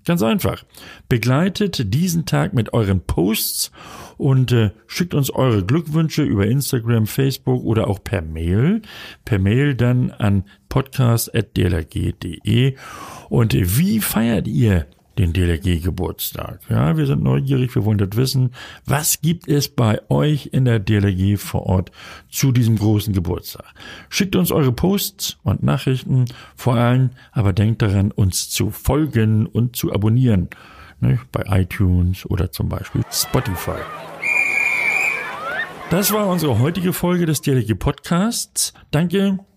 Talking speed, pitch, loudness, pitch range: 135 wpm, 125 Hz, -19 LUFS, 105-145 Hz